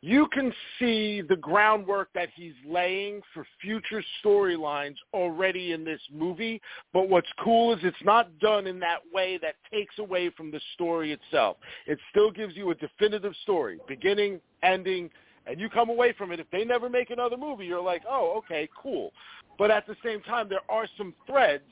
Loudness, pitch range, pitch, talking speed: -27 LUFS, 175-220 Hz, 195 Hz, 185 wpm